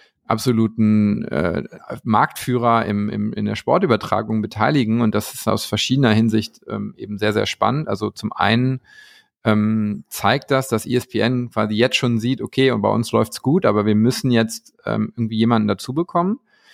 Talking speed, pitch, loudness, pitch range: 170 wpm, 115 Hz, -19 LUFS, 105-125 Hz